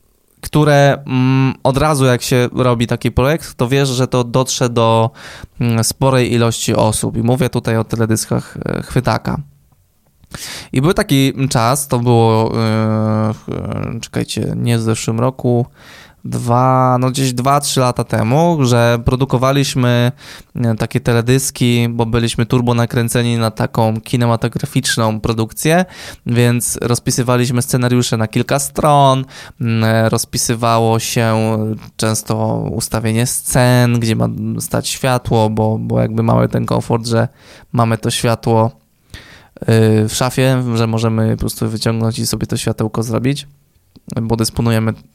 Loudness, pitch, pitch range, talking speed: -15 LUFS, 120 Hz, 115-130 Hz, 125 wpm